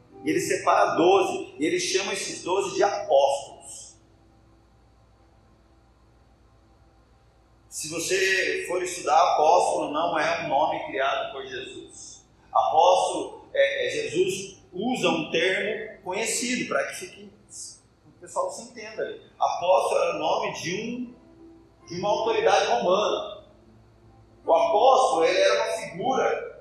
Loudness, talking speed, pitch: -24 LUFS, 120 wpm, 180 Hz